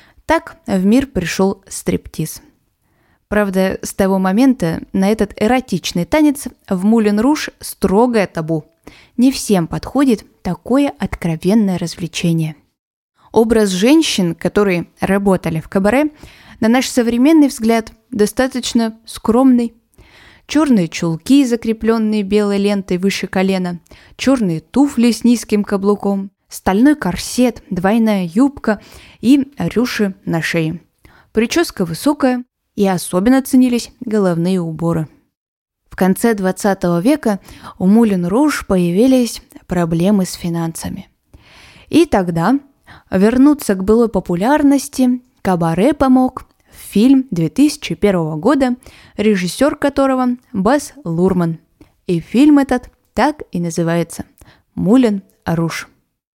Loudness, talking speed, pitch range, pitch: -15 LUFS, 105 wpm, 185-255 Hz, 210 Hz